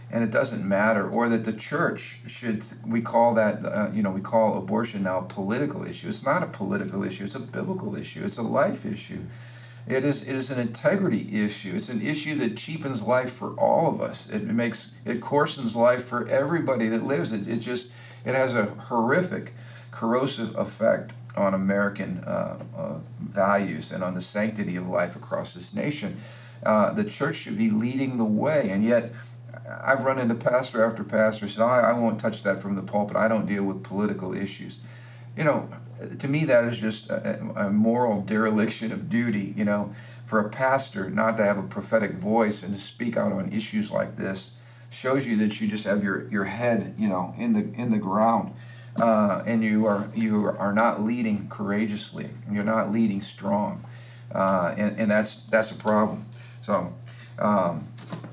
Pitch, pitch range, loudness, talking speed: 115 Hz, 105-120 Hz, -26 LUFS, 190 wpm